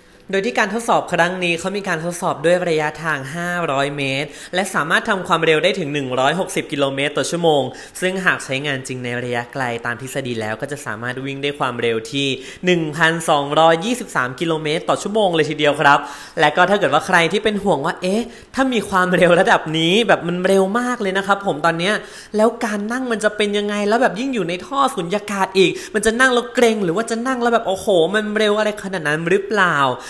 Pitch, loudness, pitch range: 175 Hz, -18 LUFS, 145-210 Hz